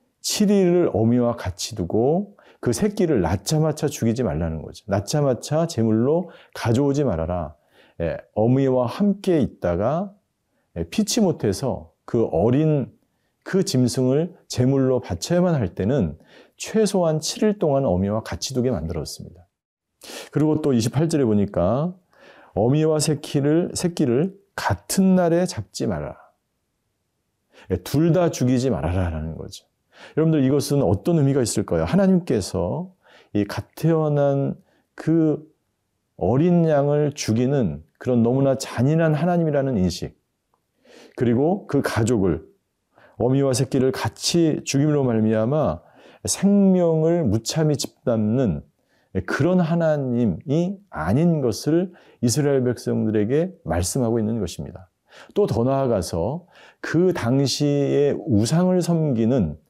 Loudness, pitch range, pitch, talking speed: -21 LUFS, 115-165 Hz, 140 Hz, 255 characters per minute